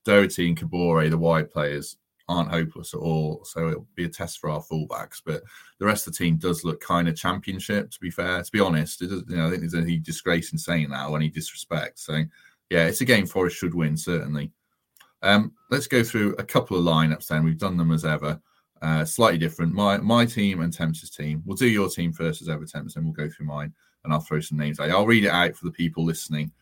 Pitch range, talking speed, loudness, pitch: 80-90 Hz, 240 wpm, -24 LUFS, 85 Hz